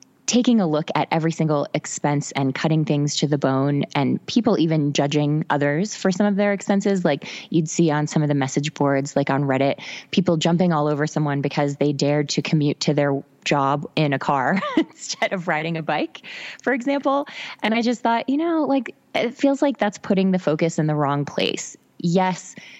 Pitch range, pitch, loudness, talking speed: 145-205 Hz, 160 Hz, -21 LUFS, 205 wpm